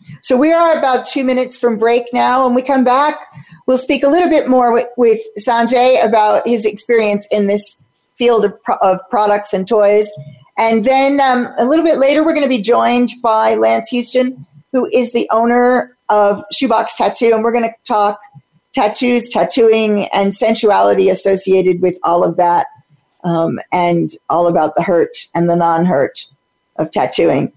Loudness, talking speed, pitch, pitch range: -13 LUFS, 175 wpm, 225 Hz, 190-250 Hz